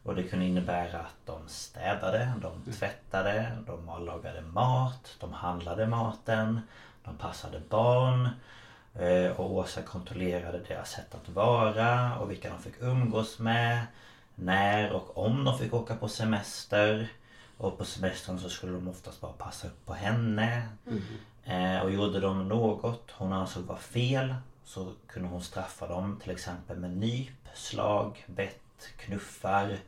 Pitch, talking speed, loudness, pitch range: 105 Hz, 145 wpm, -32 LUFS, 90-115 Hz